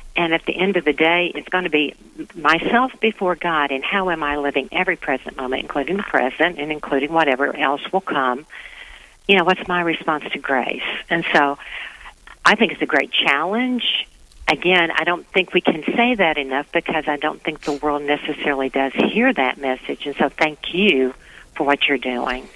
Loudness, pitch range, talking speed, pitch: -19 LUFS, 145-185 Hz, 195 wpm, 160 Hz